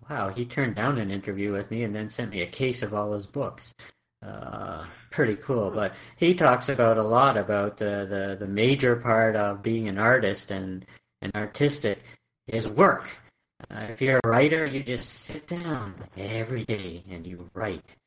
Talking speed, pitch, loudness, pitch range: 185 wpm, 110 Hz, -26 LUFS, 100-125 Hz